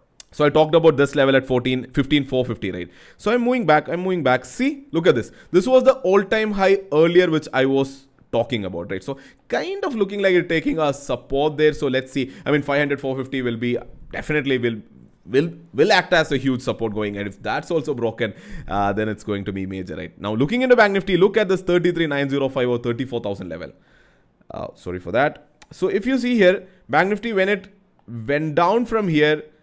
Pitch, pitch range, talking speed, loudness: 145 Hz, 120-185 Hz, 215 wpm, -20 LUFS